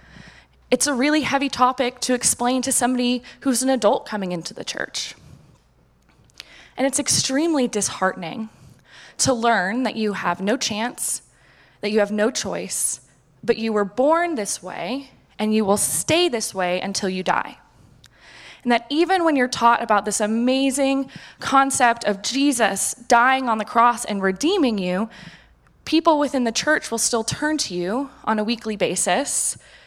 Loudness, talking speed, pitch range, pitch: -21 LUFS, 160 wpm, 210-270 Hz, 235 Hz